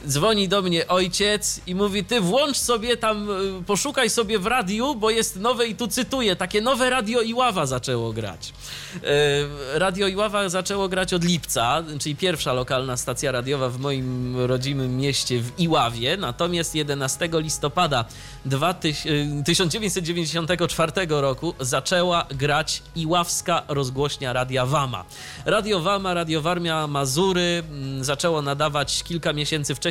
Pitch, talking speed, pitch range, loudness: 165 Hz, 130 wpm, 140-195 Hz, -22 LUFS